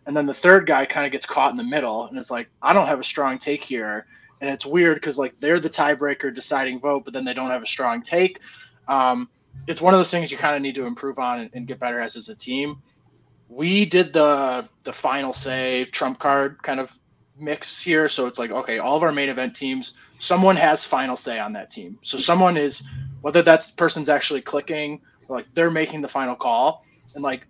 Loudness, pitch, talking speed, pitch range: -21 LUFS, 140 Hz, 230 wpm, 130-155 Hz